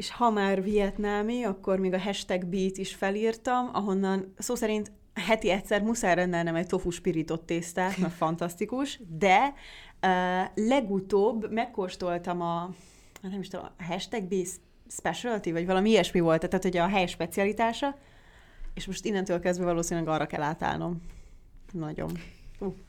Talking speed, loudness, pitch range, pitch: 145 wpm, -29 LUFS, 175-210 Hz, 190 Hz